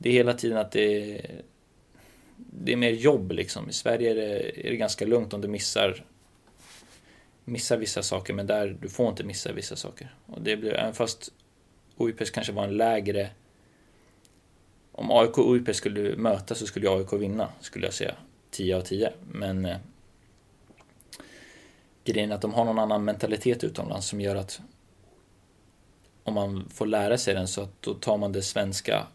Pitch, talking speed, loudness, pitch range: 105 Hz, 180 wpm, -28 LUFS, 100-115 Hz